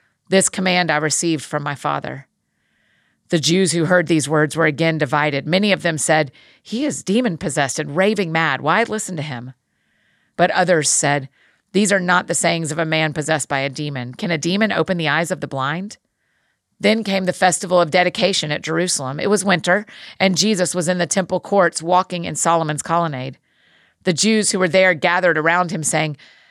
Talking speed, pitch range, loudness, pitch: 195 wpm, 155-185 Hz, -18 LUFS, 170 Hz